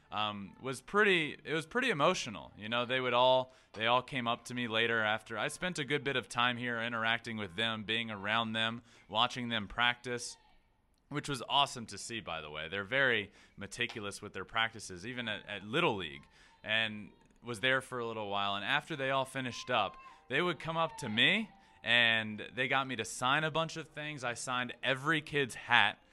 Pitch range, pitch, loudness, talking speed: 110-135 Hz, 120 Hz, -33 LUFS, 205 wpm